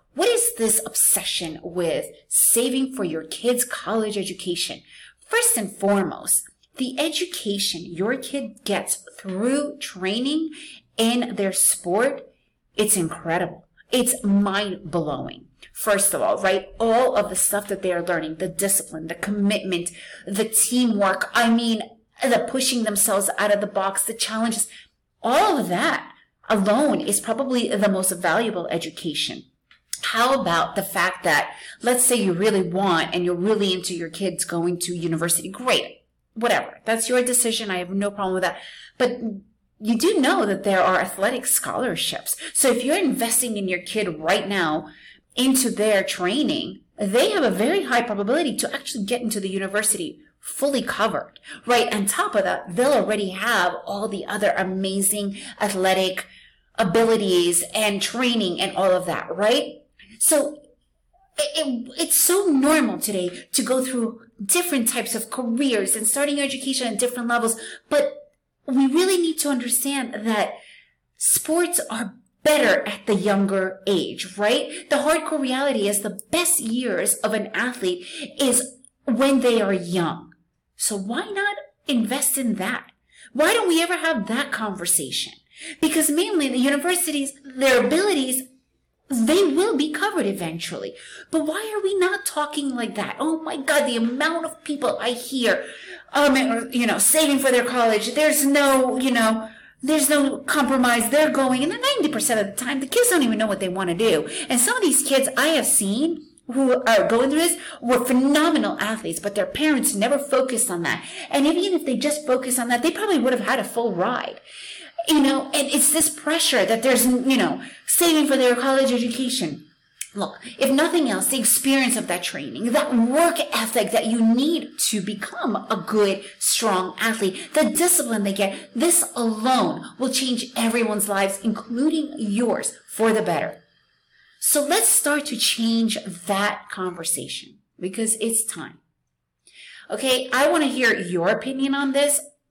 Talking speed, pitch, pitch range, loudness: 165 wpm, 240 Hz, 205-285 Hz, -21 LUFS